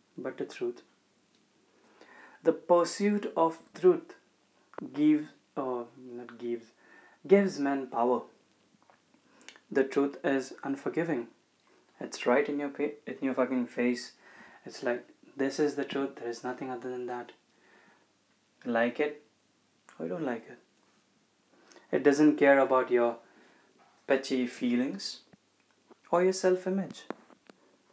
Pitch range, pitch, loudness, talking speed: 125-185 Hz, 140 Hz, -30 LUFS, 120 wpm